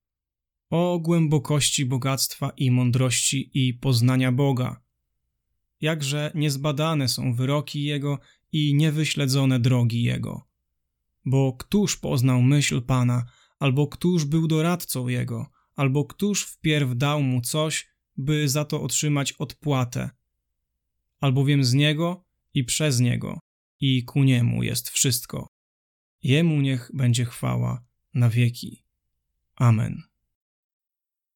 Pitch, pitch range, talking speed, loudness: 135 Hz, 120-145 Hz, 105 wpm, -23 LUFS